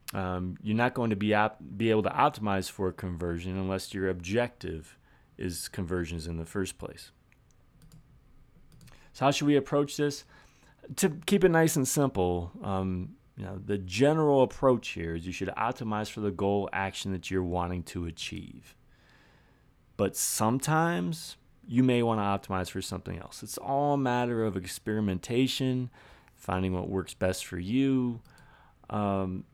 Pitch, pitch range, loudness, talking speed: 100 Hz, 95-130 Hz, -30 LUFS, 160 wpm